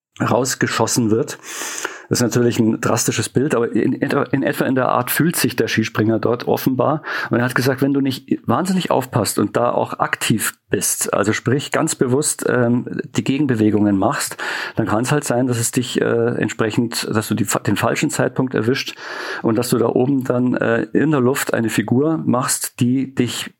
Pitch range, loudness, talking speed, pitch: 115-135 Hz, -18 LUFS, 190 wpm, 125 Hz